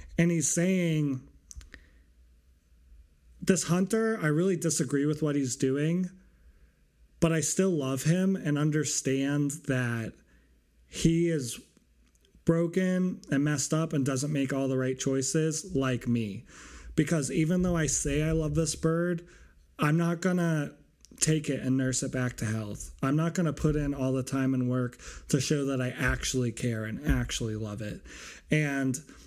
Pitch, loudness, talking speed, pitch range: 140 Hz, -29 LUFS, 155 wpm, 120-160 Hz